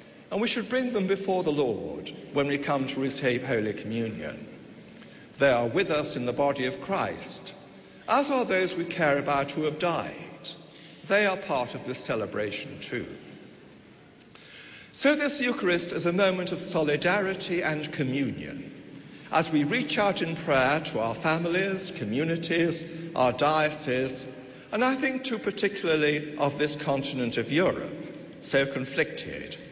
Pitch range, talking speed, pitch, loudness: 140-185 Hz, 150 wpm, 160 Hz, -27 LUFS